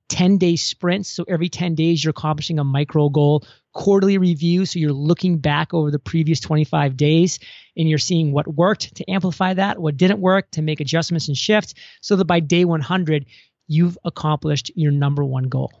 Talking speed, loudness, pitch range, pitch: 190 wpm, -19 LUFS, 150-180 Hz, 165 Hz